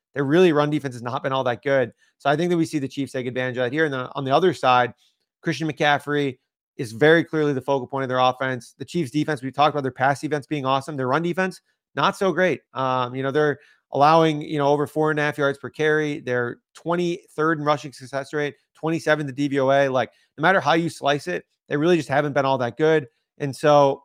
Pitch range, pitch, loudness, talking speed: 135-155 Hz, 145 Hz, -22 LUFS, 250 wpm